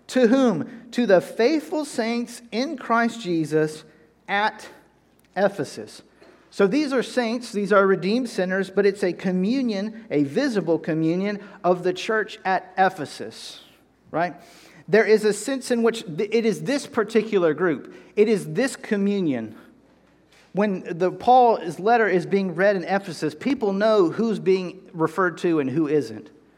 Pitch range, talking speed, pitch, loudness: 180-230 Hz, 145 wpm, 200 Hz, -22 LUFS